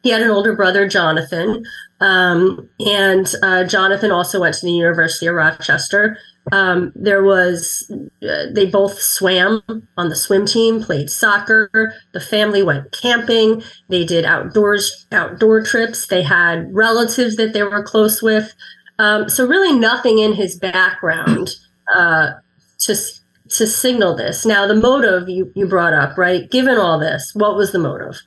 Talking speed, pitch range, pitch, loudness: 155 wpm, 180-220 Hz, 205 Hz, -15 LUFS